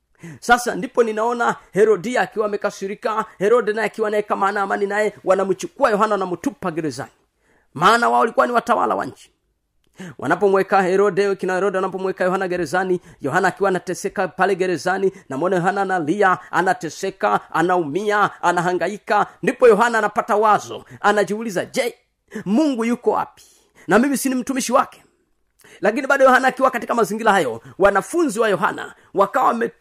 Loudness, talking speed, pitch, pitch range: -19 LUFS, 115 wpm, 200 Hz, 185-225 Hz